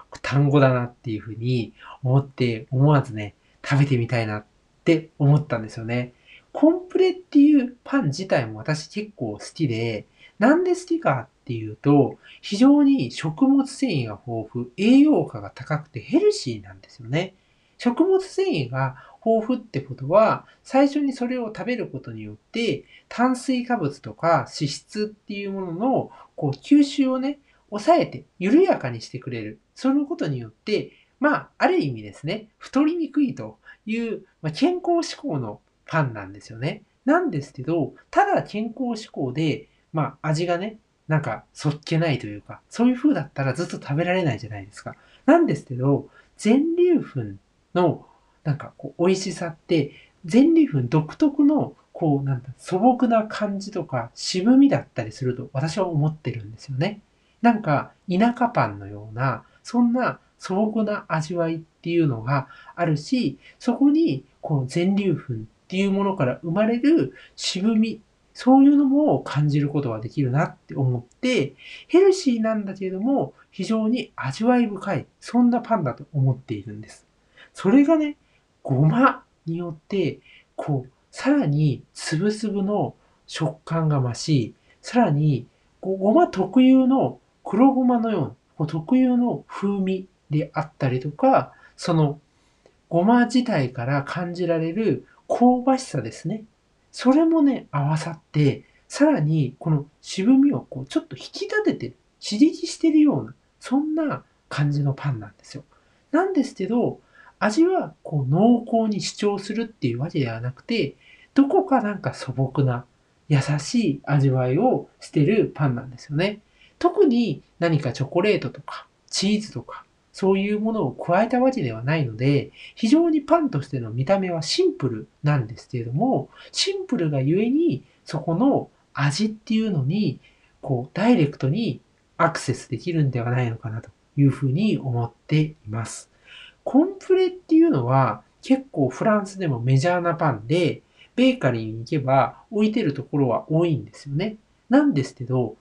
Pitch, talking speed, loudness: 170 Hz, 310 characters per minute, -22 LUFS